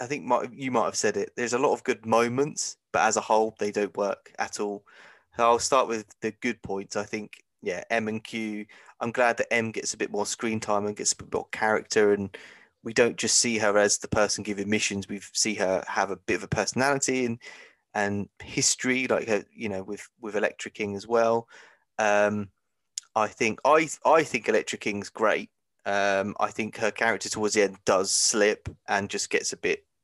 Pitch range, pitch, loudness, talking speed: 100-115 Hz, 105 Hz, -26 LUFS, 215 wpm